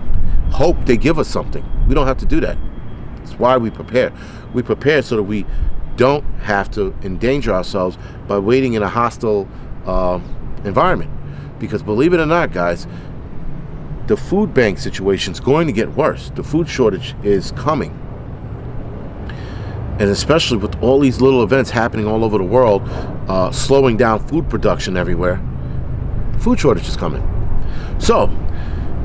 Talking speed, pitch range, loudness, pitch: 155 wpm, 100-130 Hz, -17 LUFS, 110 Hz